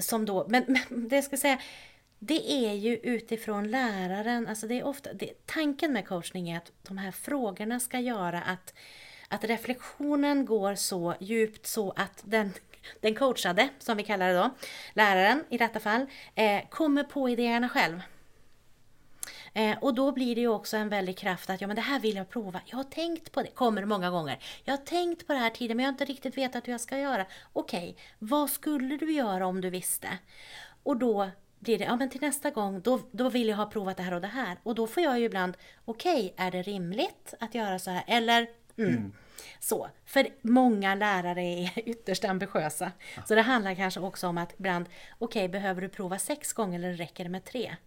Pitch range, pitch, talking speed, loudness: 190-255 Hz, 220 Hz, 210 wpm, -30 LUFS